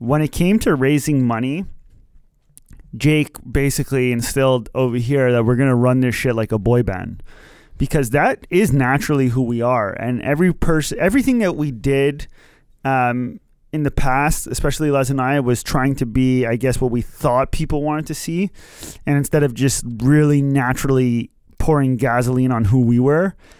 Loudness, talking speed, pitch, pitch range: -18 LUFS, 175 wpm, 135 Hz, 125-145 Hz